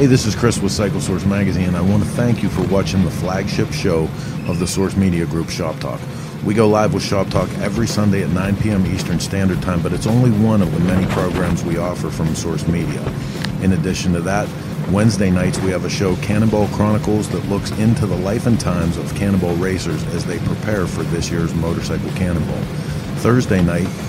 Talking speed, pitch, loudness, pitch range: 210 wpm, 100 Hz, -18 LUFS, 90-110 Hz